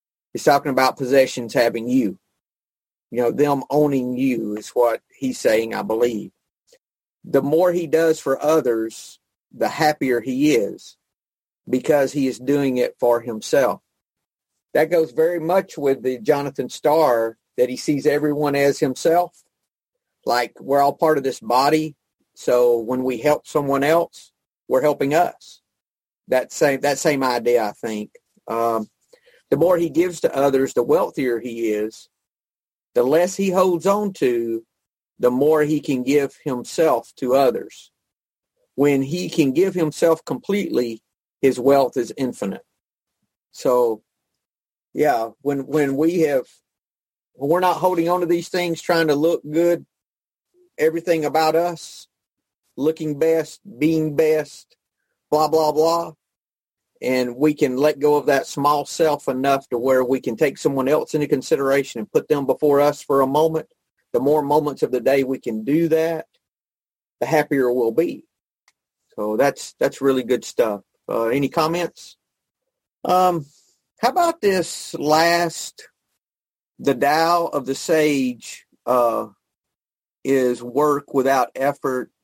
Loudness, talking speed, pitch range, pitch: -20 LUFS, 145 wpm, 130-165 Hz, 145 Hz